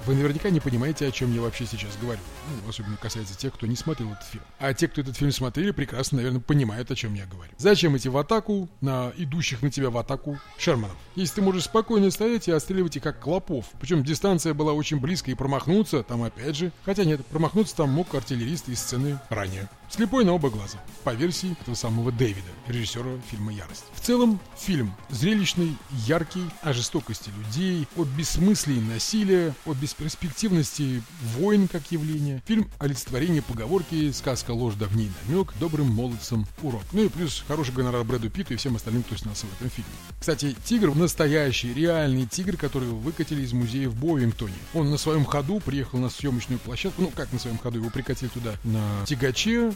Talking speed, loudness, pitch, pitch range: 190 wpm, -26 LUFS, 140 Hz, 120-165 Hz